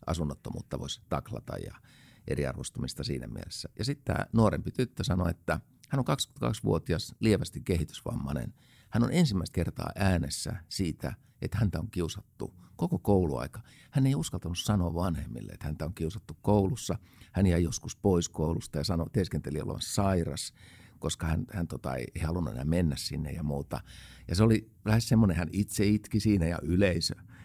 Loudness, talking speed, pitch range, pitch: -31 LUFS, 160 wpm, 85-110 Hz, 95 Hz